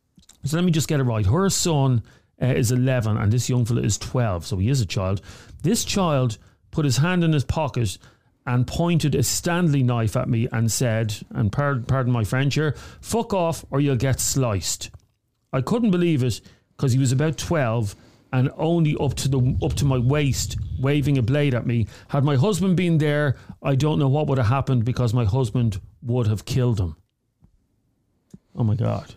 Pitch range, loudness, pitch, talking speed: 115-145 Hz, -22 LUFS, 125 Hz, 200 wpm